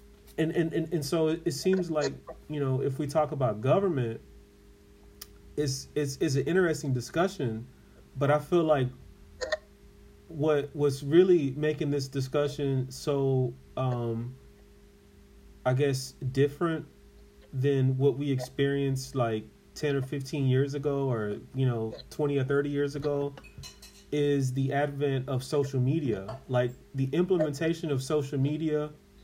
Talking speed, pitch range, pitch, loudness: 140 wpm, 125-150 Hz, 140 Hz, -29 LUFS